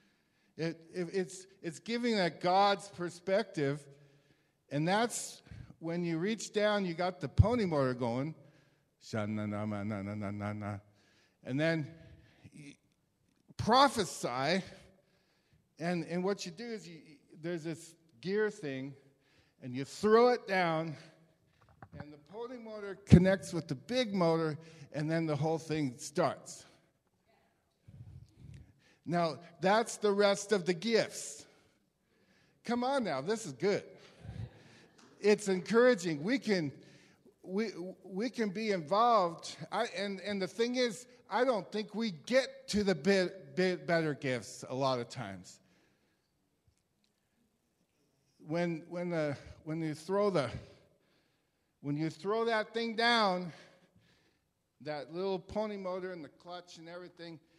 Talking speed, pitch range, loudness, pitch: 125 wpm, 150-205 Hz, -33 LUFS, 175 Hz